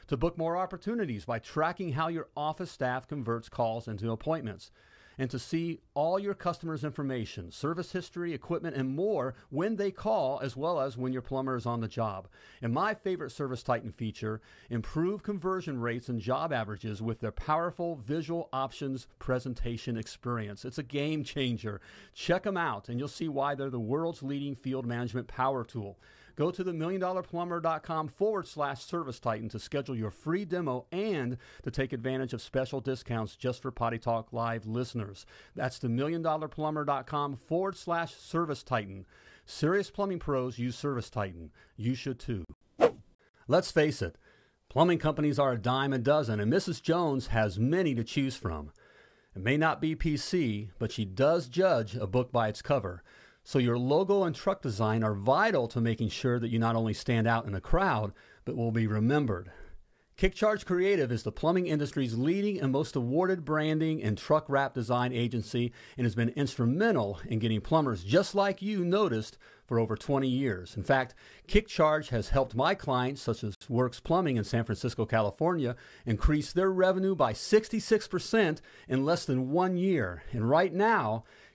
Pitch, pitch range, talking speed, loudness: 130 Hz, 115-165 Hz, 170 wpm, -31 LUFS